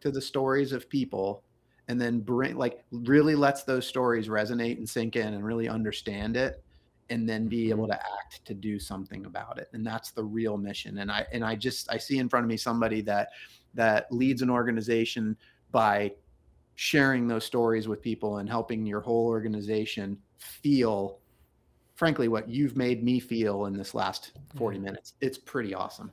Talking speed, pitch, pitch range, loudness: 185 wpm, 115 Hz, 105-125 Hz, -29 LUFS